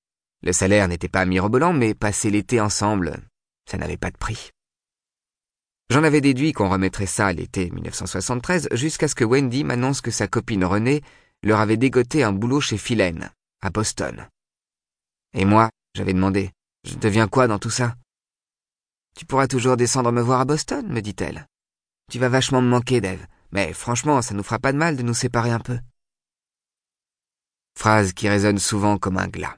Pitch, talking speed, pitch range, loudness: 110 Hz, 175 wpm, 95-125 Hz, -21 LUFS